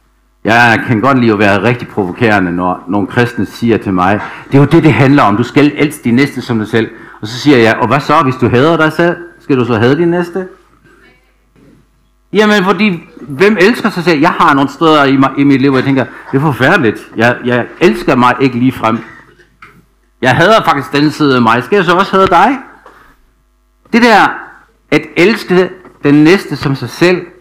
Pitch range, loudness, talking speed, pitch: 120-165 Hz, -10 LUFS, 215 wpm, 135 Hz